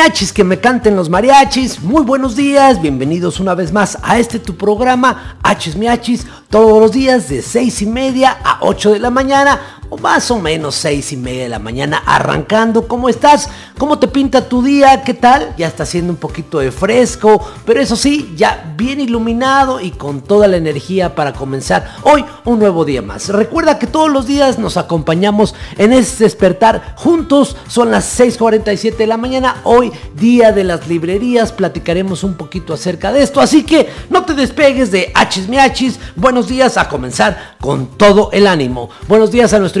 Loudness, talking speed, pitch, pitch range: -11 LUFS, 190 wpm, 220 Hz, 180-260 Hz